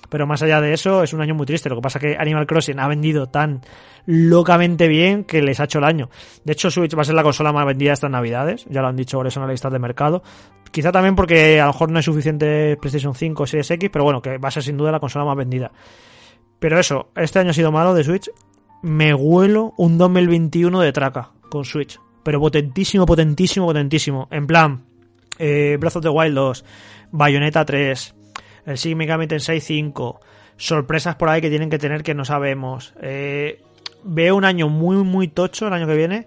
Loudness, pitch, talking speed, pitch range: -17 LUFS, 150 Hz, 215 wpm, 140-165 Hz